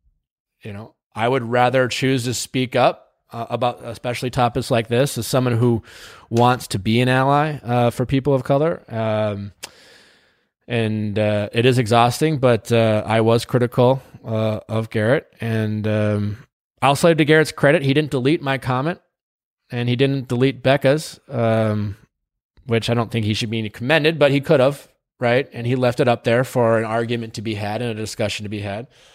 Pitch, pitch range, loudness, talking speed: 120 Hz, 110-130 Hz, -19 LUFS, 190 wpm